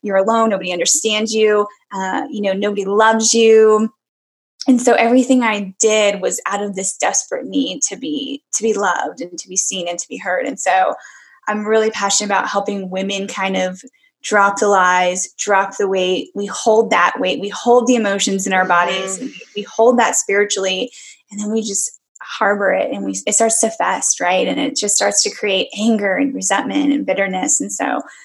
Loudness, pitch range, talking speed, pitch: -16 LUFS, 195-225 Hz, 200 wpm, 205 Hz